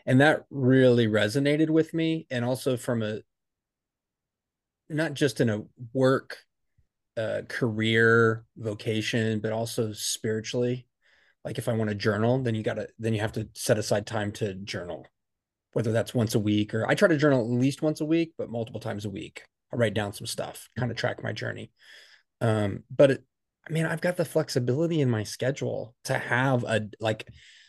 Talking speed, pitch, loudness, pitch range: 185 wpm, 120 Hz, -27 LUFS, 110-135 Hz